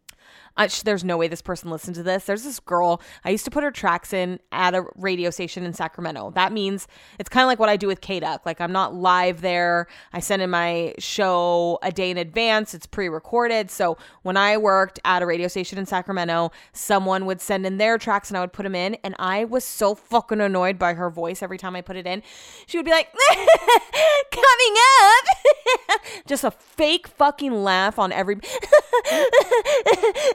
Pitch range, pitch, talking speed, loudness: 180-250 Hz, 195 Hz, 205 wpm, -20 LUFS